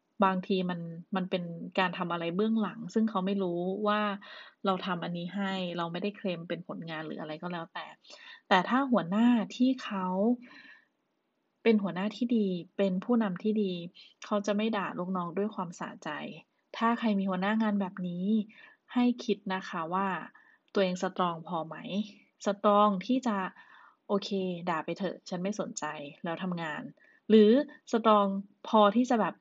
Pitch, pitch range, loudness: 195 Hz, 180-215 Hz, -30 LUFS